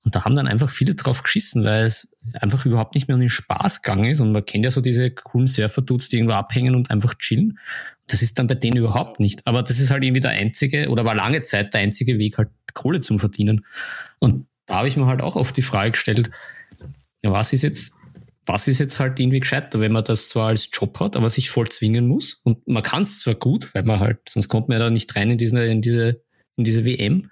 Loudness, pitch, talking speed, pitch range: -20 LUFS, 120 Hz, 250 wpm, 110-130 Hz